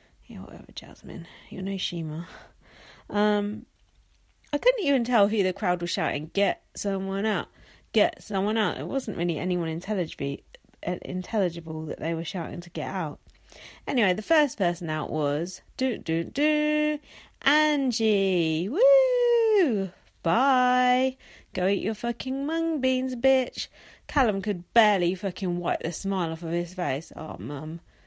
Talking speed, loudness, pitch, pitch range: 140 wpm, -26 LUFS, 200 Hz, 175-255 Hz